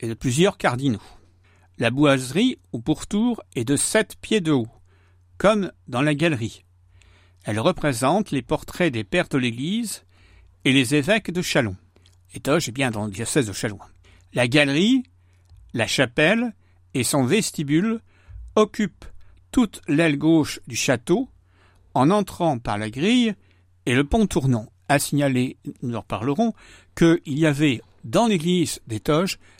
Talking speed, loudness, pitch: 150 wpm, -22 LUFS, 135 Hz